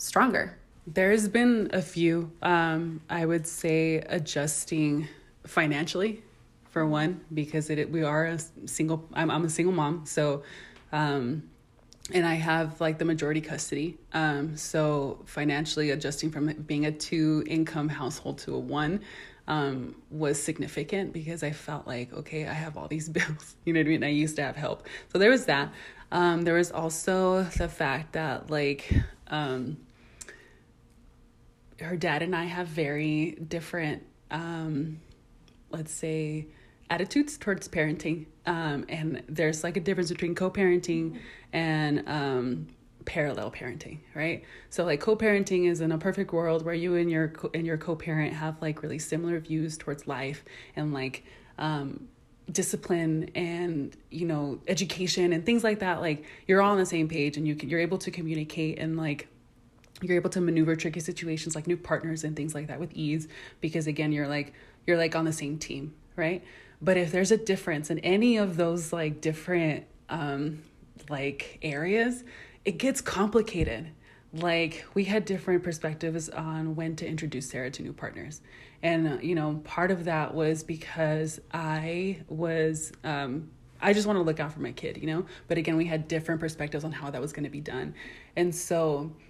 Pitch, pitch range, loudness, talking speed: 160 Hz, 150-170 Hz, -29 LUFS, 170 wpm